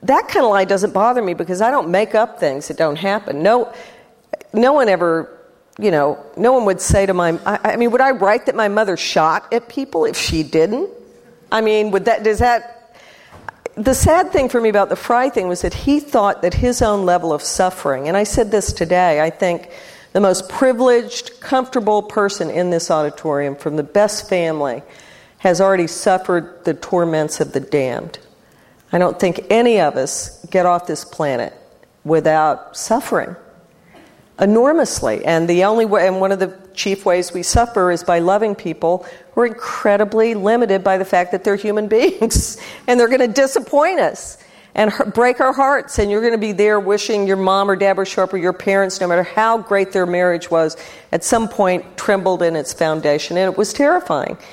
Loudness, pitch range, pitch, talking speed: -16 LUFS, 175-230 Hz, 200 Hz, 195 wpm